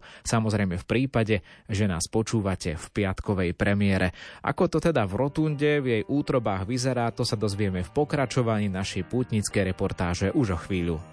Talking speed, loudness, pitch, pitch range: 155 wpm, -26 LUFS, 105 Hz, 95-125 Hz